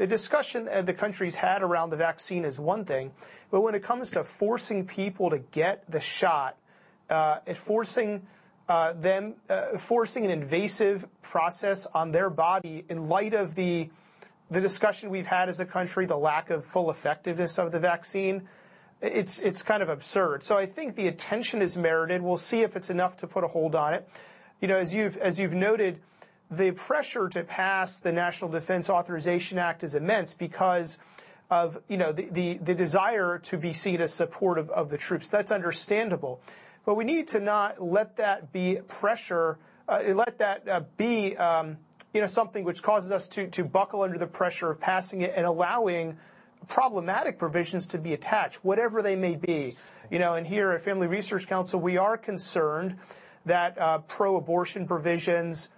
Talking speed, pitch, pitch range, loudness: 185 wpm, 185 Hz, 170-205 Hz, -28 LUFS